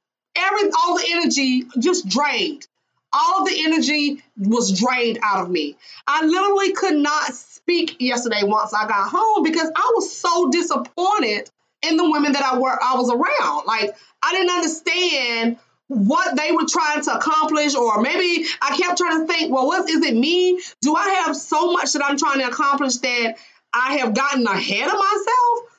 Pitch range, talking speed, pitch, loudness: 255-355 Hz, 180 wpm, 310 Hz, -19 LUFS